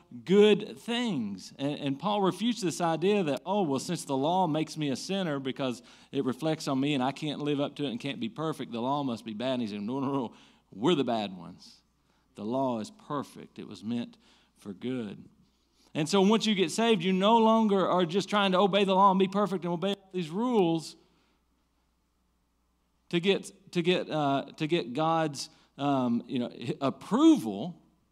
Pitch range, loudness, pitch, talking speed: 135-200 Hz, -29 LUFS, 160 Hz, 205 wpm